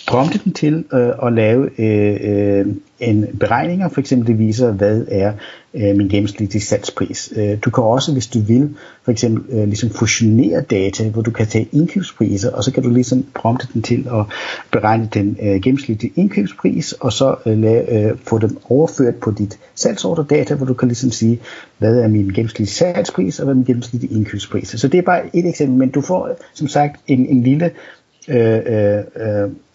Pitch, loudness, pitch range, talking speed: 120 Hz, -16 LUFS, 110-135 Hz, 195 wpm